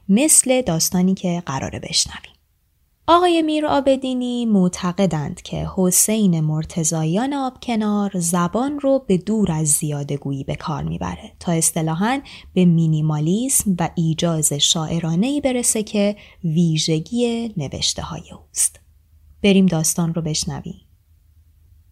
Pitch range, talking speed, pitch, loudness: 155-215 Hz, 105 wpm, 175 Hz, -19 LUFS